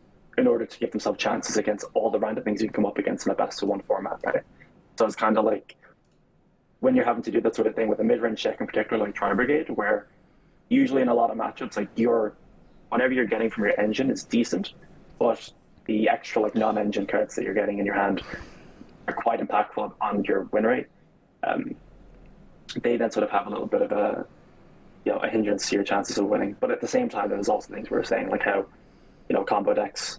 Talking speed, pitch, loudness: 240 wpm, 245 Hz, -25 LUFS